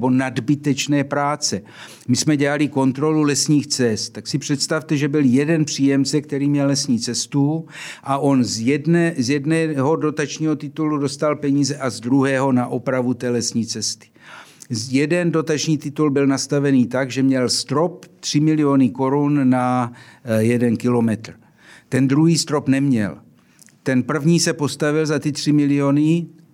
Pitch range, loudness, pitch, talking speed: 130-150 Hz, -19 LUFS, 140 Hz, 145 wpm